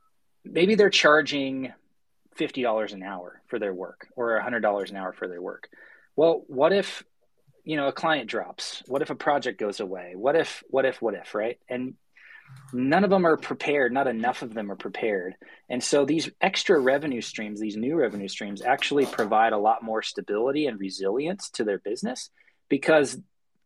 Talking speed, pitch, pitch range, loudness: 185 wpm, 125 Hz, 105-150 Hz, -25 LUFS